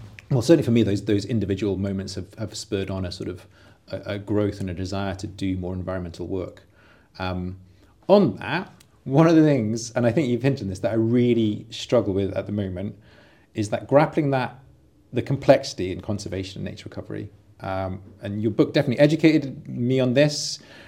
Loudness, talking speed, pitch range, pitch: -23 LUFS, 195 wpm, 95-125 Hz, 105 Hz